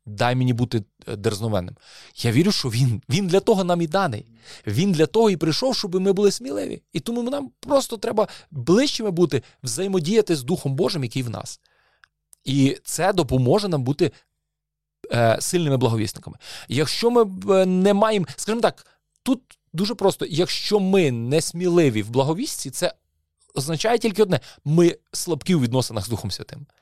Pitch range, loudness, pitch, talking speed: 125-195 Hz, -22 LUFS, 160 Hz, 155 wpm